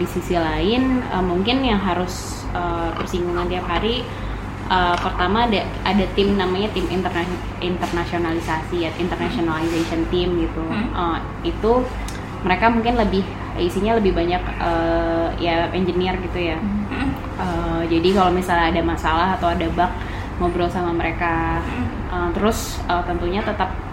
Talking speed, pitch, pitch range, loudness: 135 wpm, 175 Hz, 165-185 Hz, -21 LUFS